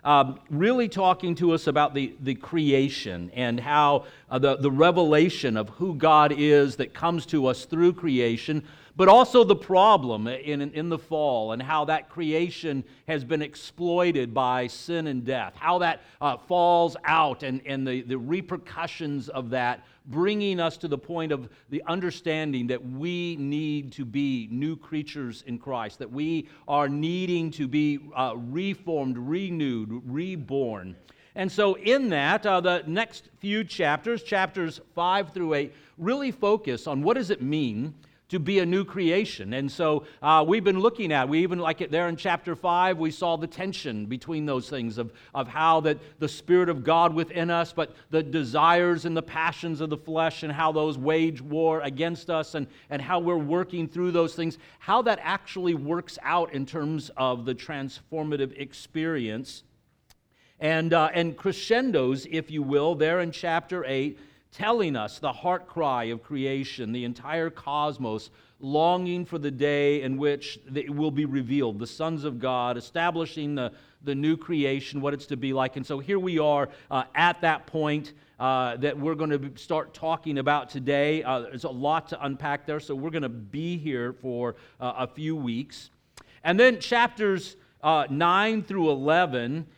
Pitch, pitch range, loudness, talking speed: 155 Hz, 135-170 Hz, -26 LUFS, 175 wpm